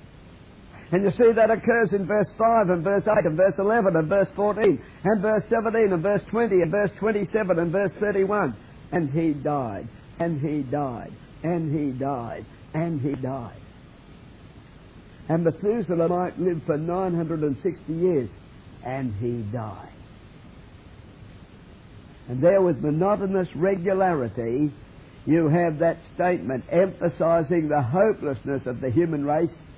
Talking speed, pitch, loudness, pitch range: 135 wpm, 165 Hz, -24 LUFS, 140-195 Hz